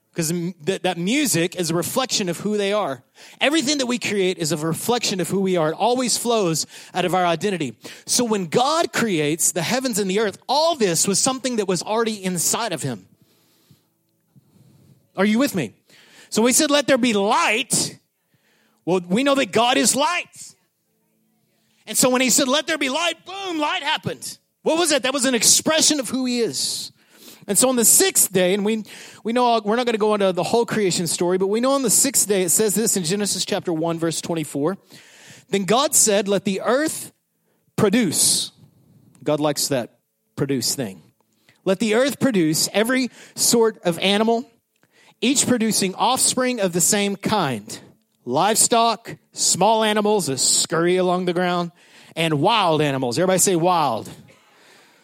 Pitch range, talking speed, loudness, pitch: 180-245 Hz, 180 wpm, -19 LUFS, 205 Hz